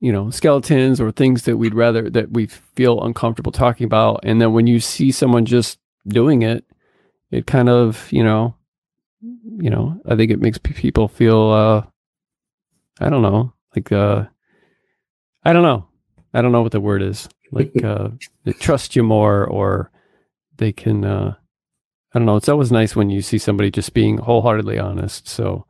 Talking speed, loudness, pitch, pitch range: 180 wpm, -17 LUFS, 115 Hz, 105-120 Hz